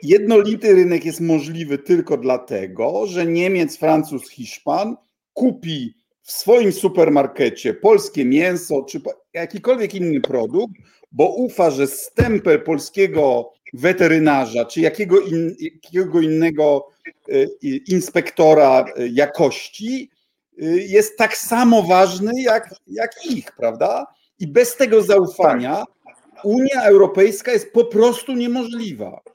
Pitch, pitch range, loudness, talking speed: 195 Hz, 160-245 Hz, -17 LUFS, 100 wpm